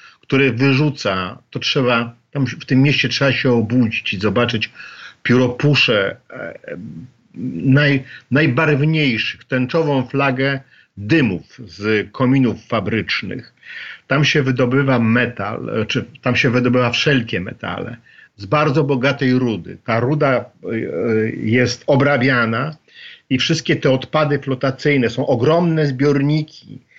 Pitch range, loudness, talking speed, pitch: 120-145 Hz, -17 LUFS, 105 wpm, 130 Hz